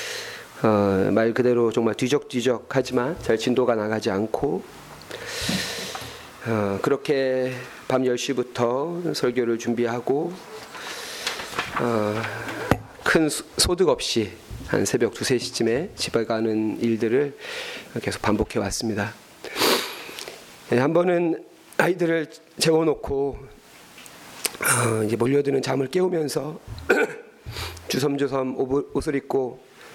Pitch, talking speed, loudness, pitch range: 125 Hz, 200 characters per minute, -24 LUFS, 115-145 Hz